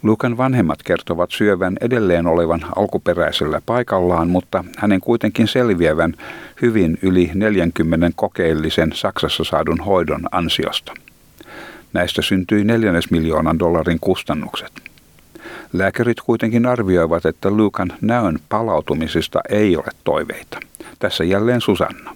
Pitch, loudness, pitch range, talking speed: 95 Hz, -18 LUFS, 85-110 Hz, 105 wpm